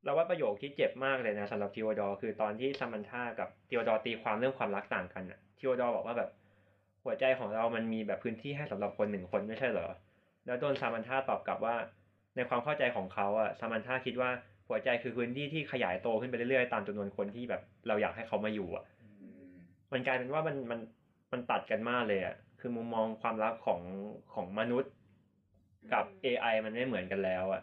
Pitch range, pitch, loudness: 100-125 Hz, 110 Hz, -35 LUFS